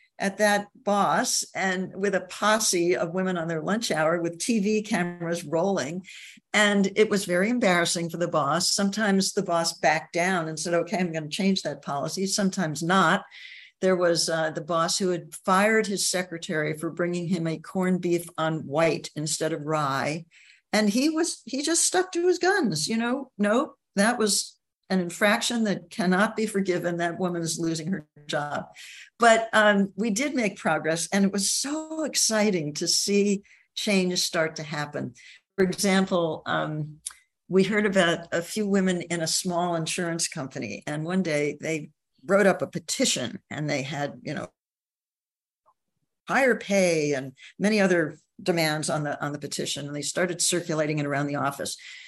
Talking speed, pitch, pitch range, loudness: 175 wpm, 180 Hz, 165-205 Hz, -25 LUFS